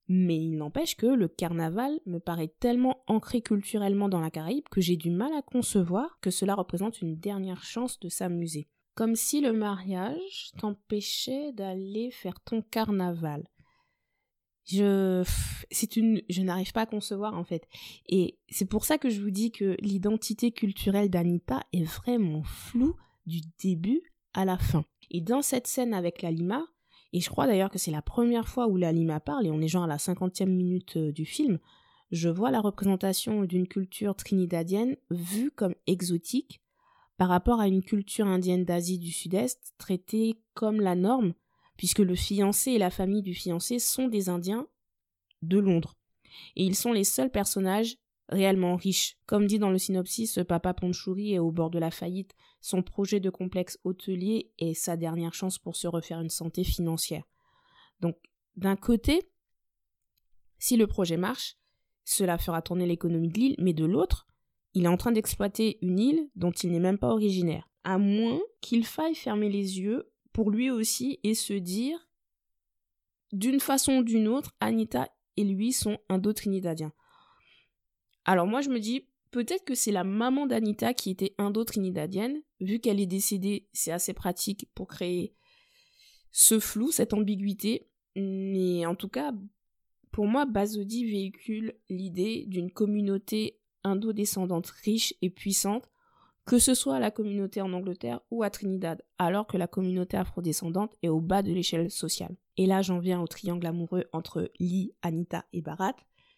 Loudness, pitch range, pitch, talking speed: -29 LUFS, 180-225 Hz, 195 Hz, 170 wpm